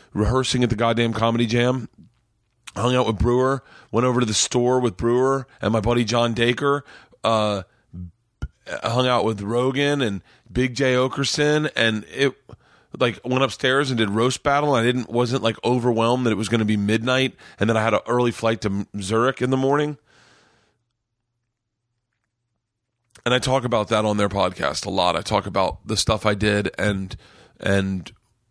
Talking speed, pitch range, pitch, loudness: 175 wpm, 110-125 Hz, 115 Hz, -21 LUFS